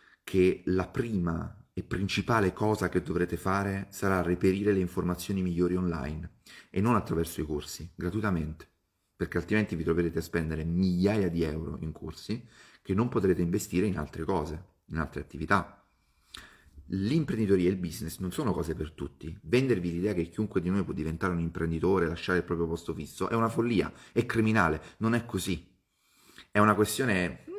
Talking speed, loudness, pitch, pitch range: 170 wpm, -30 LUFS, 90 Hz, 85-100 Hz